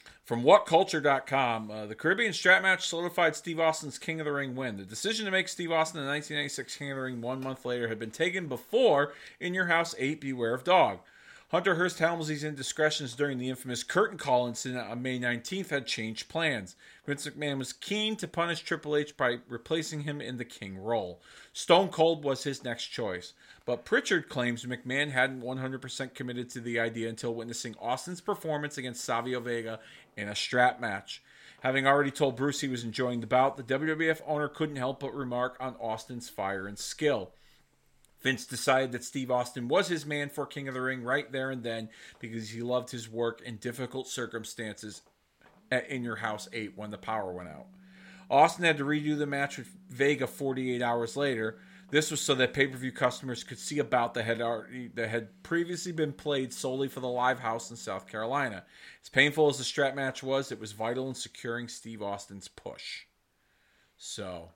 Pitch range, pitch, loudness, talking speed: 120-150 Hz, 130 Hz, -30 LUFS, 190 wpm